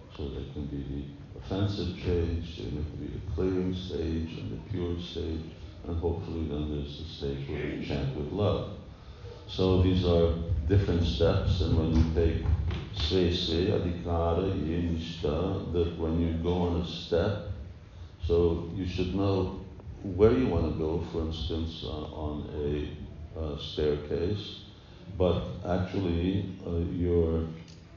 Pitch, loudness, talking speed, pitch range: 85 Hz, -30 LUFS, 135 wpm, 80-95 Hz